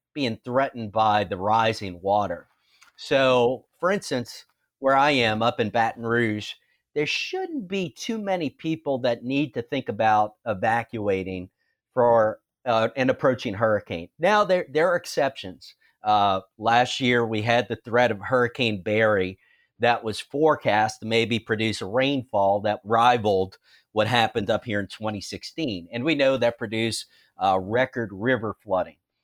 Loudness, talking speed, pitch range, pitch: -24 LUFS, 150 wpm, 105-135 Hz, 115 Hz